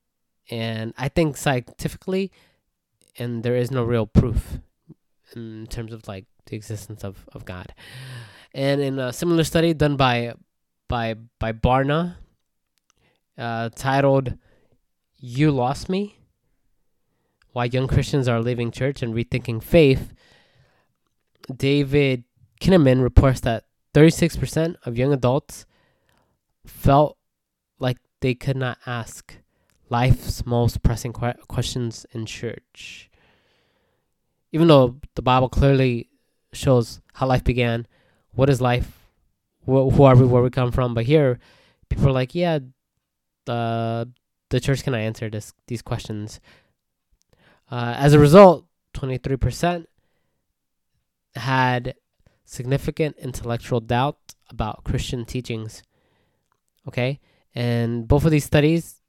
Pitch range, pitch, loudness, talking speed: 115-140 Hz, 125 Hz, -21 LUFS, 120 wpm